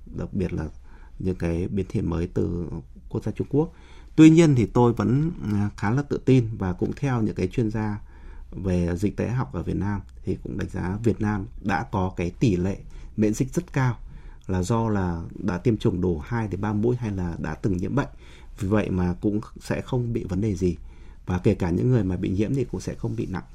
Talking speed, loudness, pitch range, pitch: 235 wpm, -25 LUFS, 90-115 Hz, 100 Hz